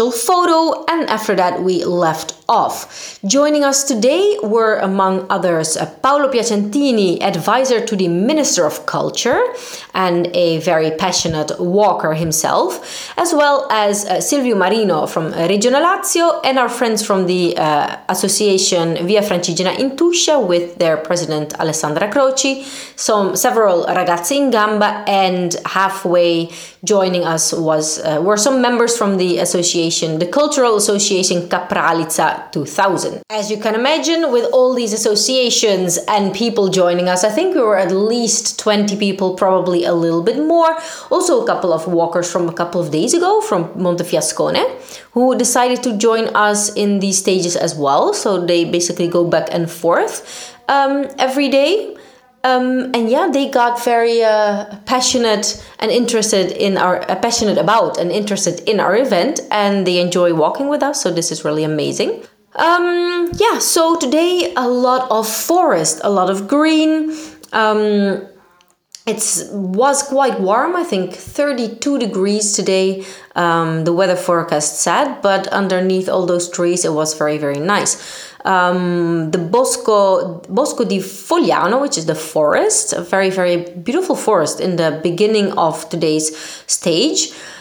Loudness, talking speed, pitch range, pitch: -15 LUFS, 150 wpm, 175-255 Hz, 205 Hz